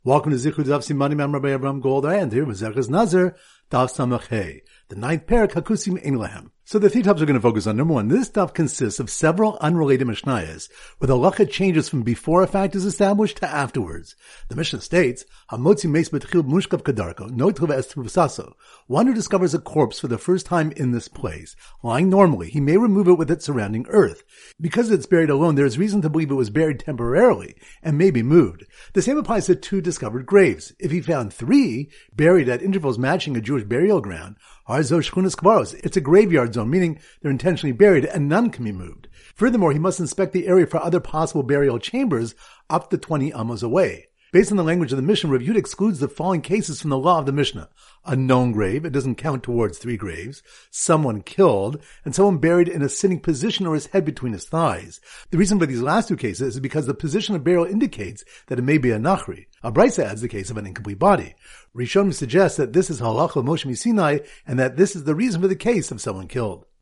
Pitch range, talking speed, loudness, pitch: 130-185 Hz, 205 wpm, -20 LUFS, 155 Hz